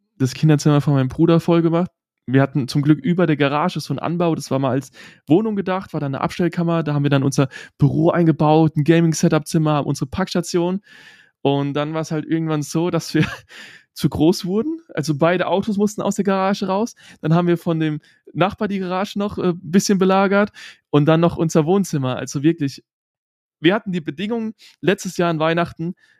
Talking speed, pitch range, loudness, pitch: 195 wpm, 150-185 Hz, -19 LUFS, 165 Hz